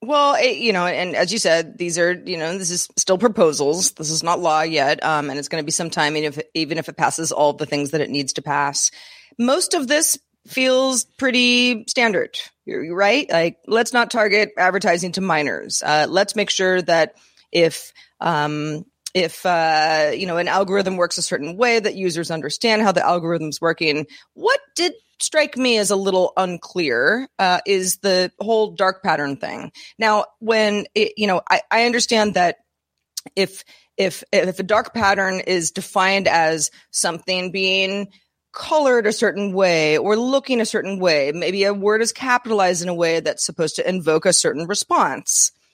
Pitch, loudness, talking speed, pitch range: 190 Hz, -19 LUFS, 185 wpm, 165-220 Hz